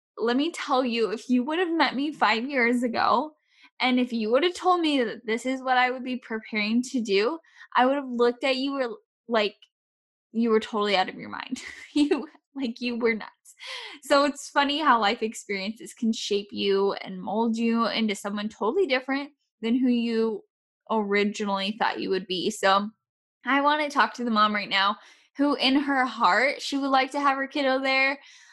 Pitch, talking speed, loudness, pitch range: 245 Hz, 200 wpm, -25 LUFS, 220-280 Hz